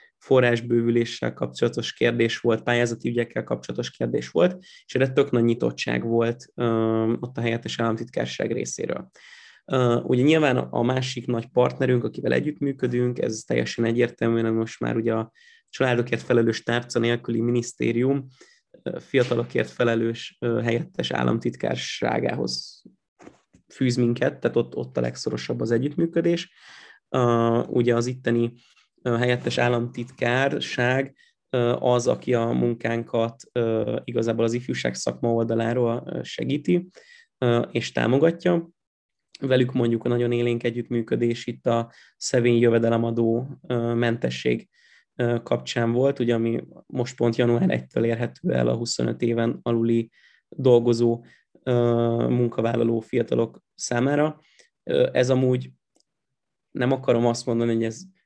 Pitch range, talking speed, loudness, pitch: 115-125 Hz, 110 wpm, -24 LUFS, 120 Hz